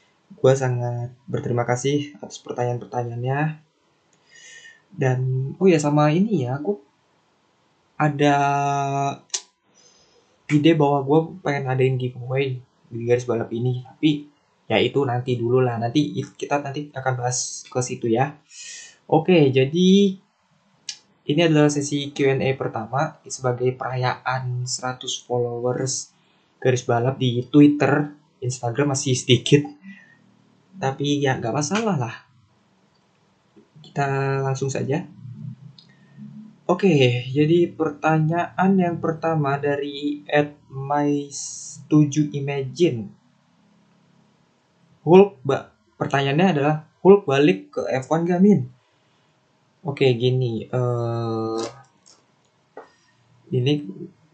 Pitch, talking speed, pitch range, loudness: 140 Hz, 100 wpm, 125-155 Hz, -21 LUFS